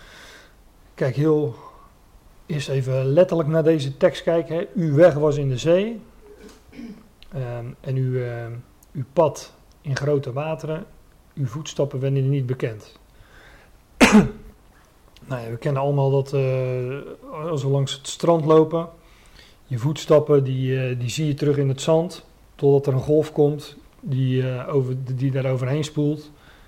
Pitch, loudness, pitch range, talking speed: 140 Hz, -21 LUFS, 130-155 Hz, 150 wpm